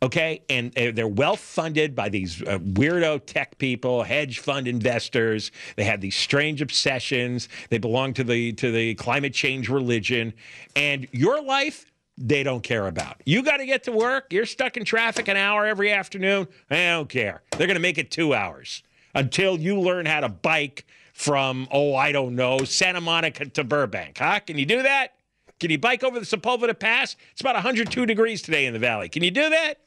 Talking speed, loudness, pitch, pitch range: 195 wpm, -23 LUFS, 145 Hz, 125-205 Hz